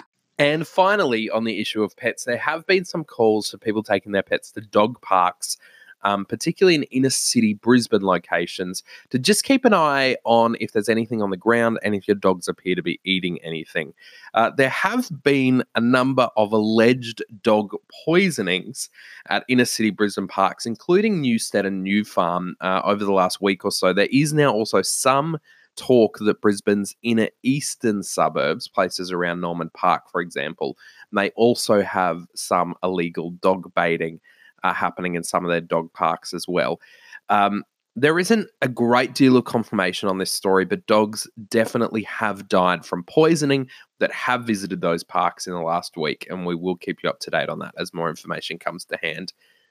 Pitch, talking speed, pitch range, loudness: 110 Hz, 185 wpm, 95-130 Hz, -21 LUFS